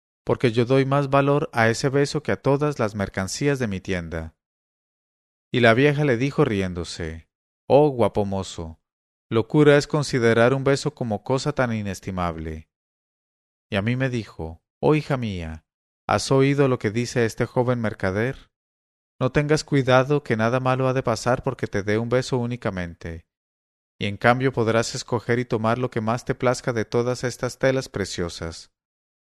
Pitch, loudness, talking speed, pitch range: 115 Hz, -22 LUFS, 165 wpm, 90-130 Hz